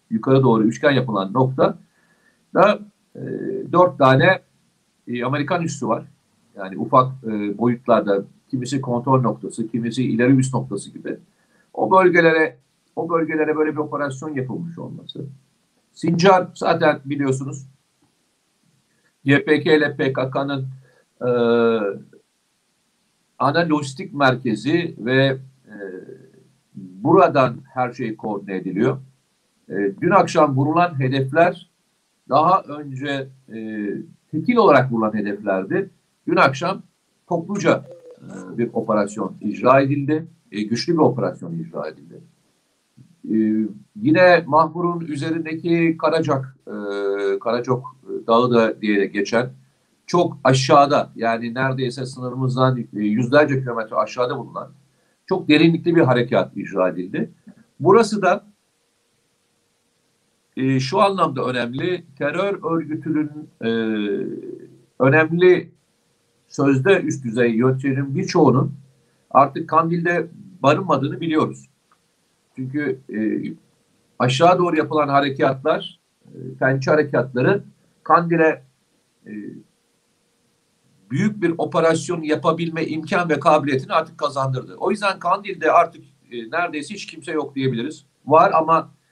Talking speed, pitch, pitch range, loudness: 105 wpm, 145 Hz, 125-170 Hz, -19 LUFS